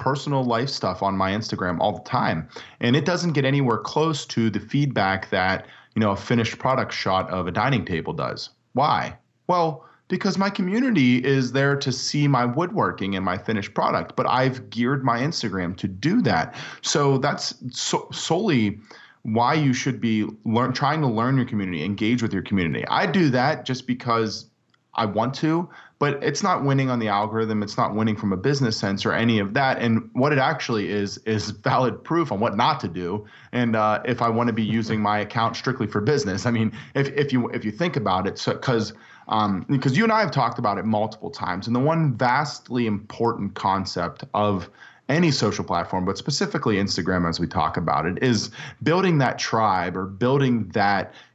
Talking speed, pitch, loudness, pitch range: 200 wpm, 115 Hz, -23 LUFS, 105-140 Hz